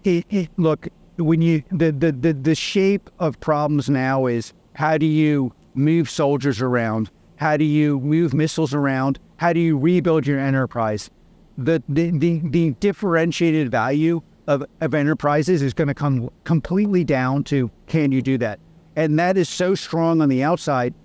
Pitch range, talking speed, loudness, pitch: 140-165 Hz, 170 wpm, -20 LUFS, 155 Hz